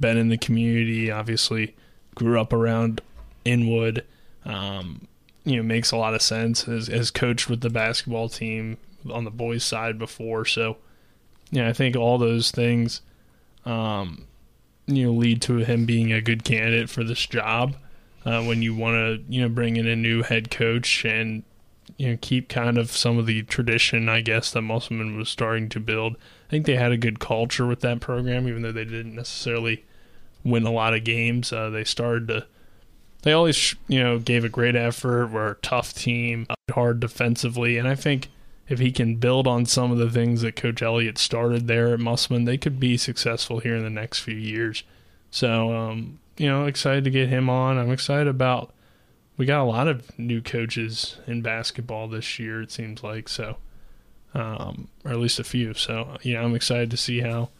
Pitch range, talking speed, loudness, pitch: 115-120 Hz, 200 wpm, -23 LUFS, 115 Hz